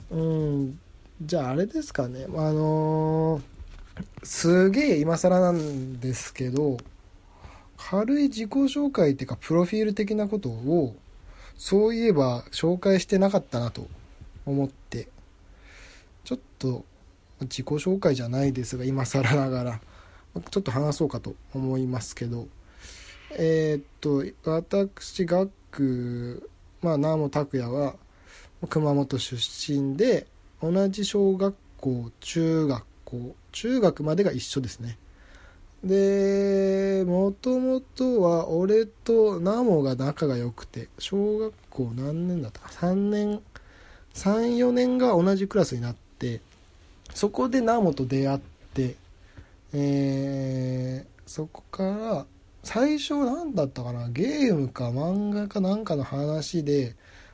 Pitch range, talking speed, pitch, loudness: 120-195 Hz, 220 characters per minute, 145 Hz, -26 LUFS